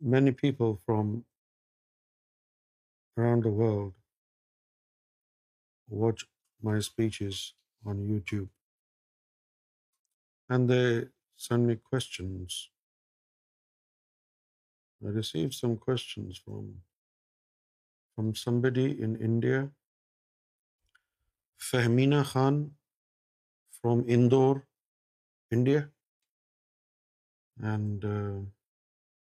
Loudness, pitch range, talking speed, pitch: -29 LUFS, 100-125 Hz, 60 wpm, 115 Hz